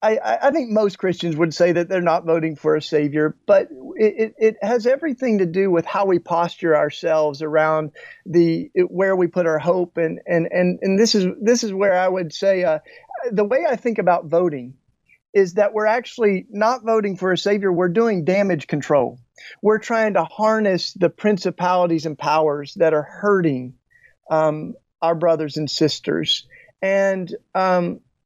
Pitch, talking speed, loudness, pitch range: 180 Hz, 180 wpm, -19 LUFS, 160-210 Hz